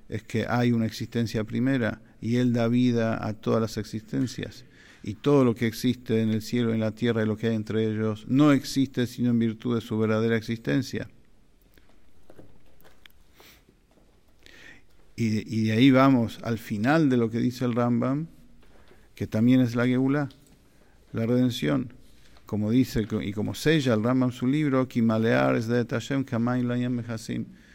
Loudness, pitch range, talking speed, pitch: -25 LUFS, 110-125 Hz, 165 wpm, 115 Hz